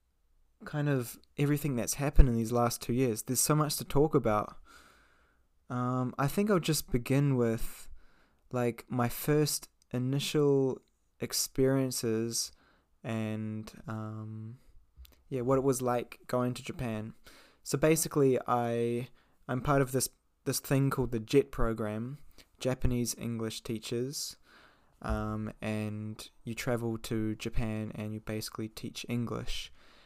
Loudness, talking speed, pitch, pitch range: -32 LUFS, 130 wpm, 120 Hz, 110-135 Hz